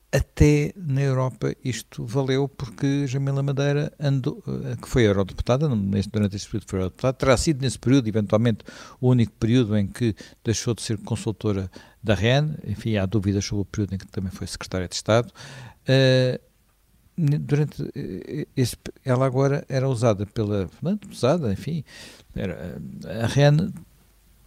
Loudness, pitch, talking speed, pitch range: -24 LUFS, 120 Hz, 145 wpm, 105-140 Hz